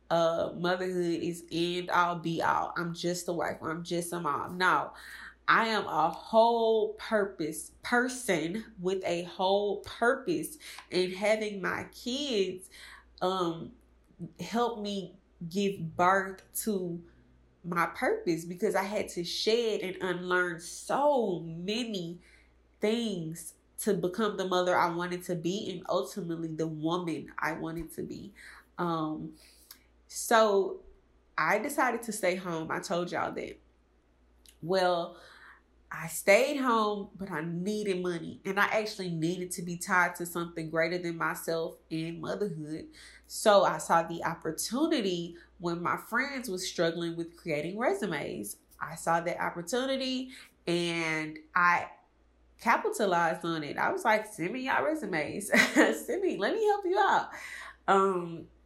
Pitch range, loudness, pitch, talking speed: 170-210 Hz, -30 LUFS, 180 Hz, 135 wpm